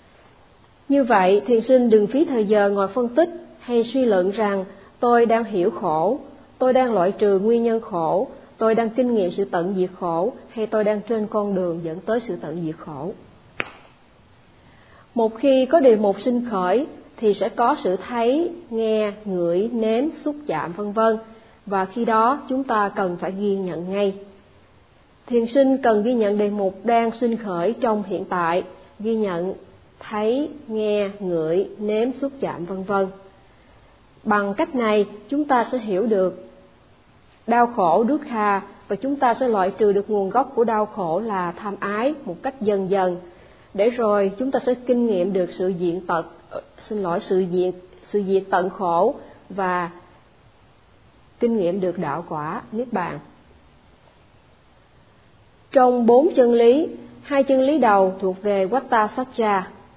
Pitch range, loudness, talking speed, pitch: 185-240 Hz, -21 LUFS, 170 wpm, 210 Hz